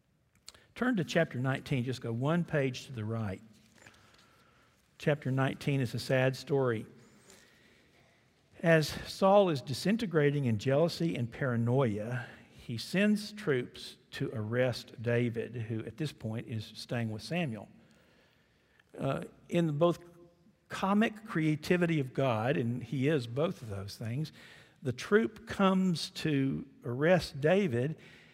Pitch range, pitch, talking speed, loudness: 120-165 Hz, 135 Hz, 125 wpm, -32 LUFS